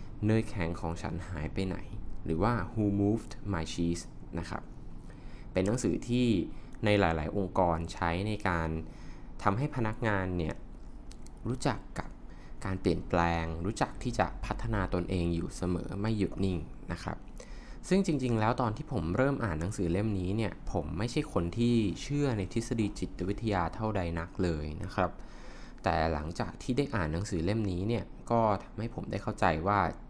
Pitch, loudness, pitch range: 100 Hz, -32 LUFS, 85-110 Hz